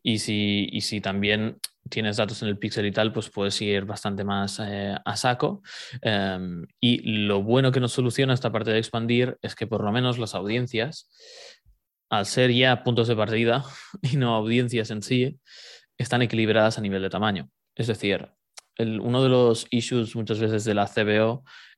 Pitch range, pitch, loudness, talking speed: 105-125 Hz, 110 Hz, -24 LUFS, 185 wpm